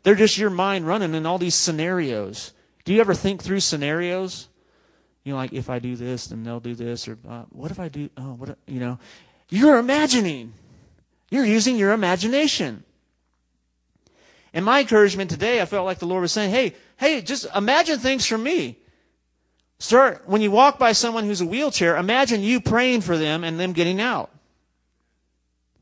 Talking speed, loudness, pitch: 180 wpm, -21 LUFS, 180 Hz